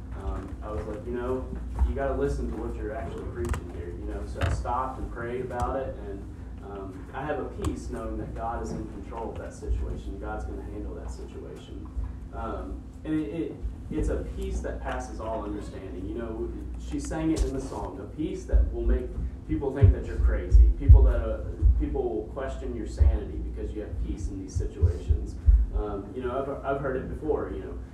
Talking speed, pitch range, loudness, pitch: 215 wpm, 85-110 Hz, -30 LUFS, 95 Hz